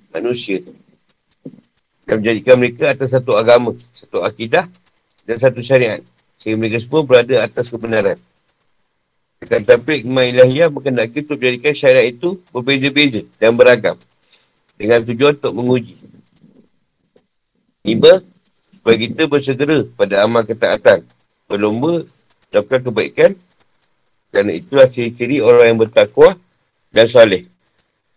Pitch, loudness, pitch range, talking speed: 130 Hz, -14 LUFS, 115-155 Hz, 110 wpm